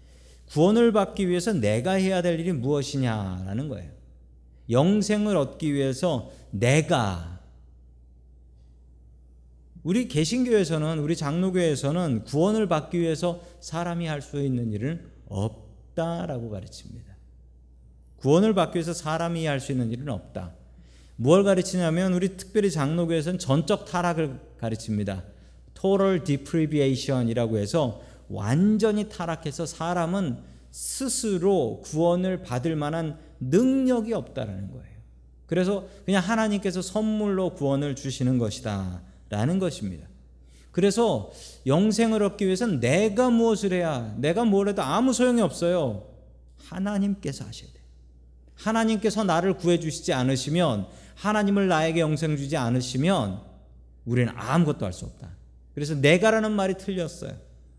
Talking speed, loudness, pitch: 310 characters per minute, -25 LUFS, 150 Hz